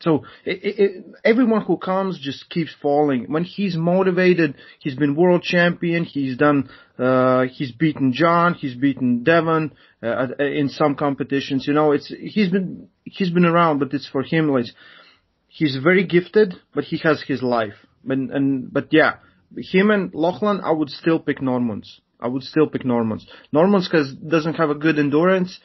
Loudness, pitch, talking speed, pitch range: -20 LUFS, 155 Hz, 175 wpm, 140-175 Hz